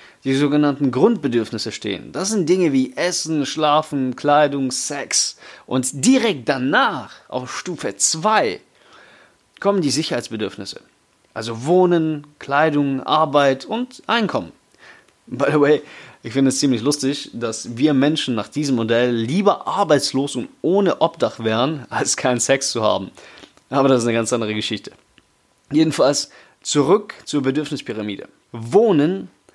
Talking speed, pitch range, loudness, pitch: 130 wpm, 125-155 Hz, -19 LUFS, 140 Hz